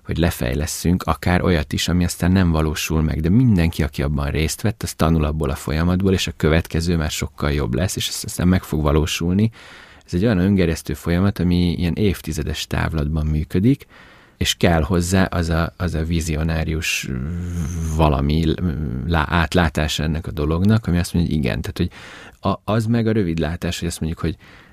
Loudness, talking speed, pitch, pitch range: -20 LUFS, 175 wpm, 85 Hz, 80-90 Hz